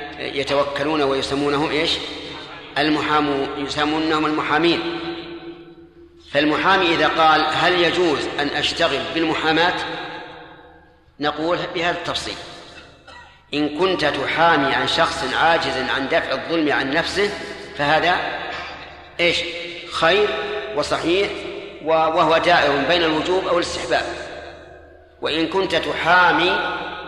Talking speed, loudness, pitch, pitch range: 90 wpm, -19 LUFS, 160 Hz, 150-180 Hz